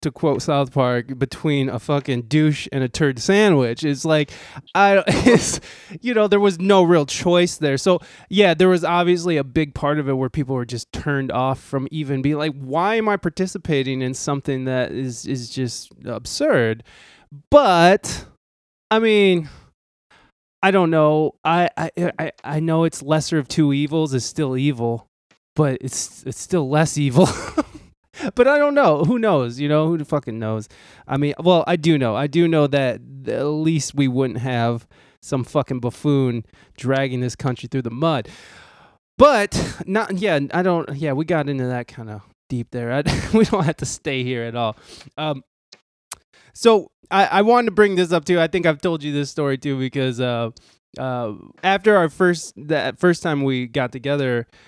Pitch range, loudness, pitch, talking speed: 130-175 Hz, -19 LUFS, 145 Hz, 185 wpm